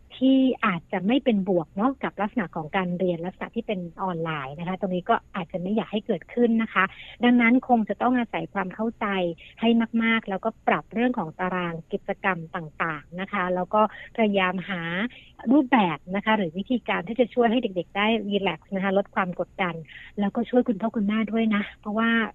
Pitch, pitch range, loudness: 200 Hz, 185-230 Hz, -25 LUFS